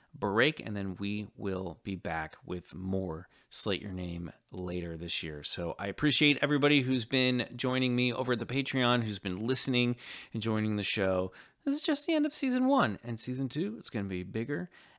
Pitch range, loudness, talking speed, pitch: 95-130 Hz, -31 LUFS, 200 wpm, 110 Hz